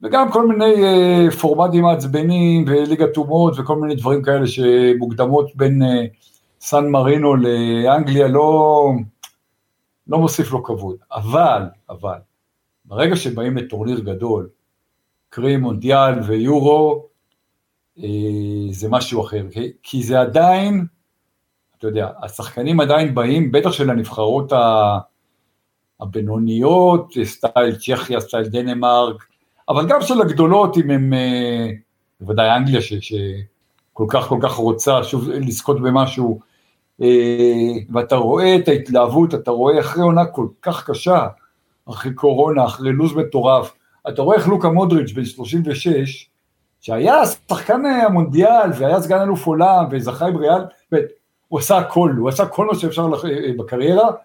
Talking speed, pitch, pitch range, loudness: 125 wpm, 135 Hz, 120-165 Hz, -16 LUFS